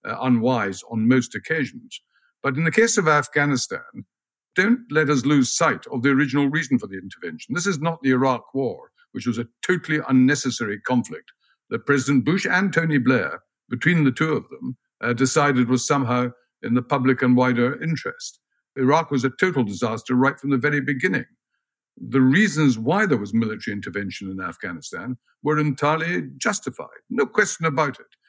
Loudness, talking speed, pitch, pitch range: -21 LUFS, 175 wpm, 135 Hz, 125-155 Hz